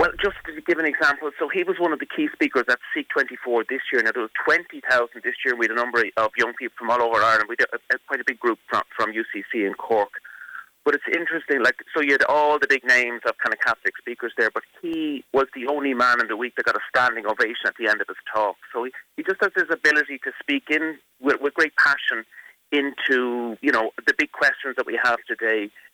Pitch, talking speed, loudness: 145 Hz, 255 wpm, -22 LUFS